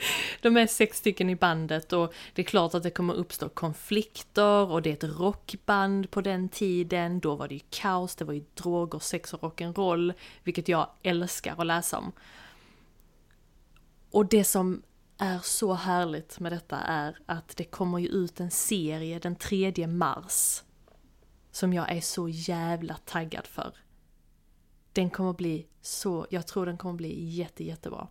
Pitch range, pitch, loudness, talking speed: 165-190 Hz, 175 Hz, -29 LUFS, 165 wpm